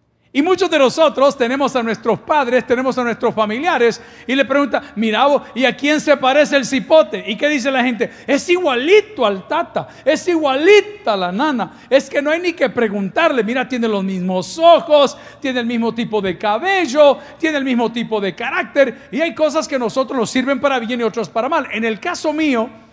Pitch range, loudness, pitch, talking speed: 230-295 Hz, -16 LUFS, 265 Hz, 205 wpm